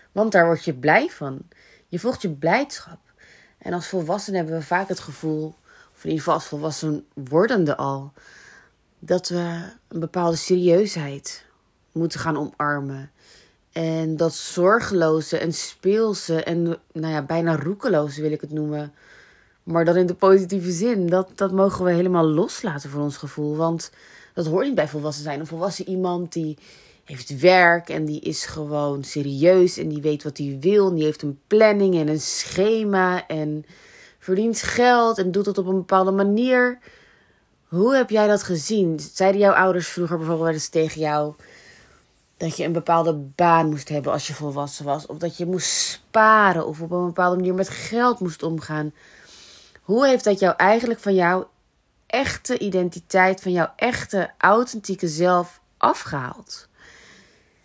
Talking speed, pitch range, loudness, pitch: 160 wpm, 155-190 Hz, -21 LUFS, 170 Hz